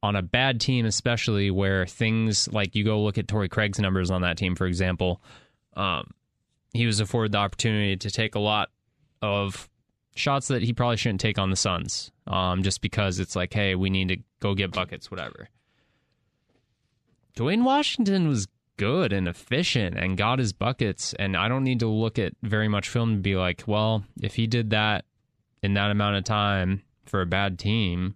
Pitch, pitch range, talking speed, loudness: 105 Hz, 95-115 Hz, 190 wpm, -25 LUFS